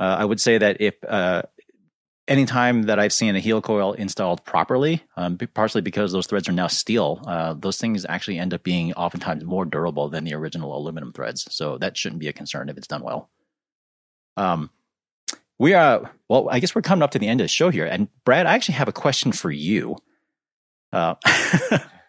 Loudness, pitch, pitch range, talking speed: -21 LUFS, 95 Hz, 85-110 Hz, 205 wpm